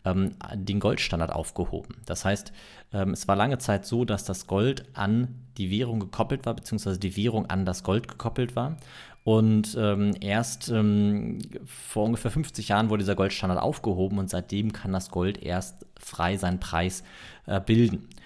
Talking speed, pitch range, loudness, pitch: 150 wpm, 95-115 Hz, -27 LUFS, 105 Hz